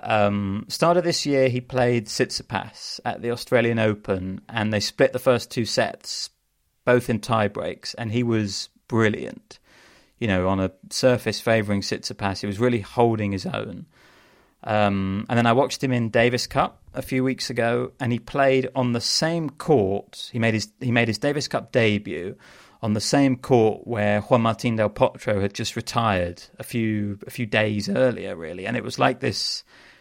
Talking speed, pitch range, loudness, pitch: 185 wpm, 105-125 Hz, -23 LUFS, 115 Hz